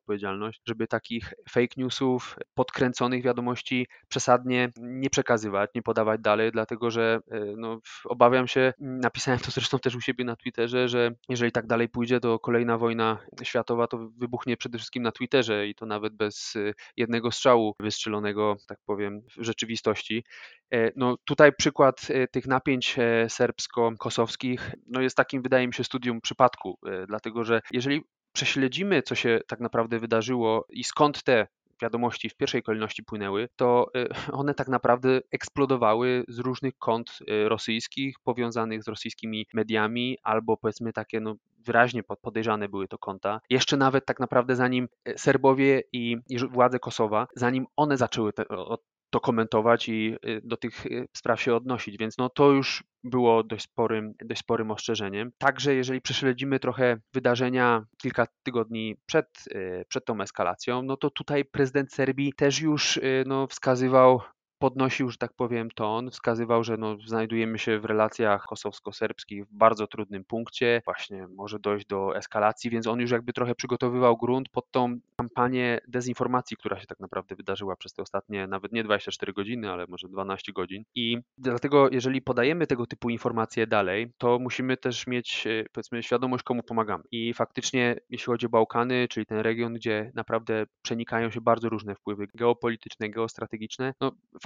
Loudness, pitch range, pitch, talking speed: -27 LUFS, 110-125 Hz, 120 Hz, 155 wpm